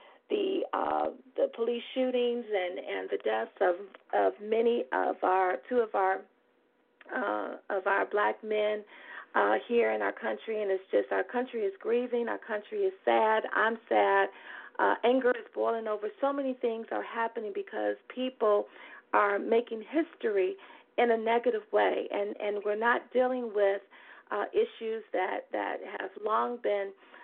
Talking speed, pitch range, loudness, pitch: 160 wpm, 205-255 Hz, -30 LUFS, 230 Hz